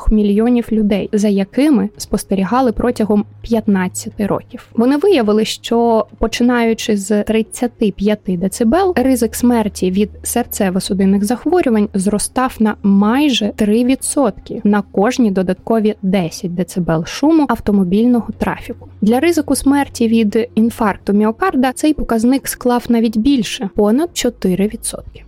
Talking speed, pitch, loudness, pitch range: 110 wpm, 220 Hz, -15 LUFS, 205-245 Hz